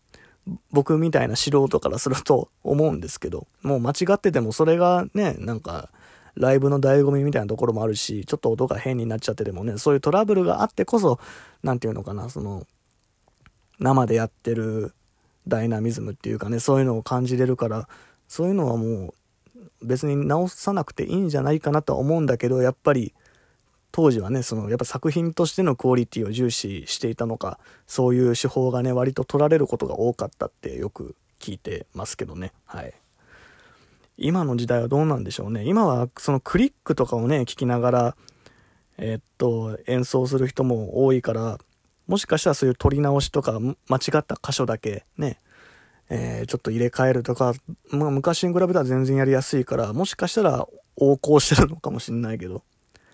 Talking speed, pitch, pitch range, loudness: 385 characters per minute, 130 Hz, 115-145 Hz, -23 LUFS